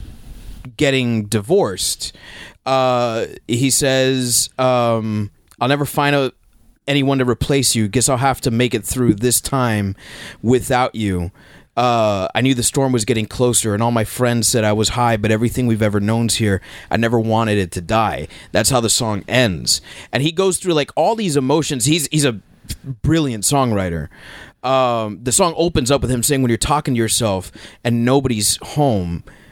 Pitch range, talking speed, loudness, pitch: 110-135 Hz, 175 wpm, -17 LUFS, 120 Hz